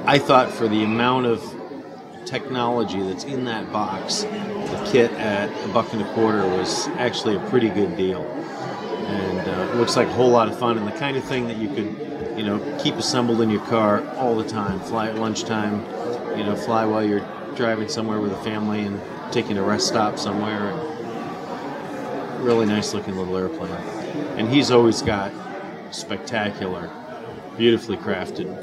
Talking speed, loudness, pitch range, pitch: 175 wpm, -22 LUFS, 105-115 Hz, 110 Hz